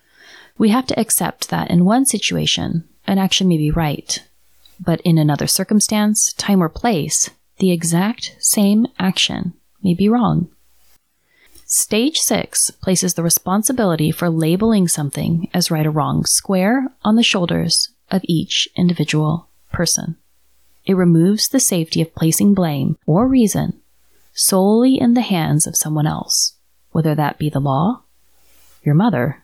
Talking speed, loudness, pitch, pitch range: 145 wpm, -16 LUFS, 175 Hz, 155-210 Hz